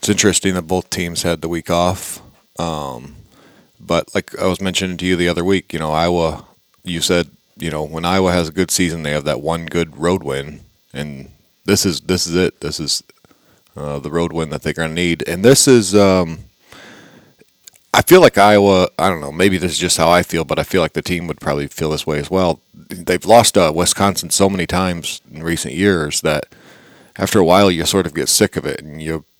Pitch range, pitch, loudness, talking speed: 80-95 Hz, 85 Hz, -16 LUFS, 225 wpm